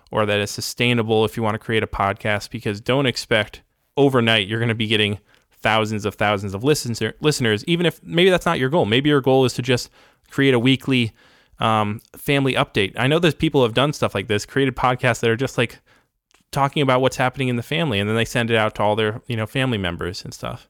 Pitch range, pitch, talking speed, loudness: 110-135 Hz, 120 Hz, 240 wpm, -20 LUFS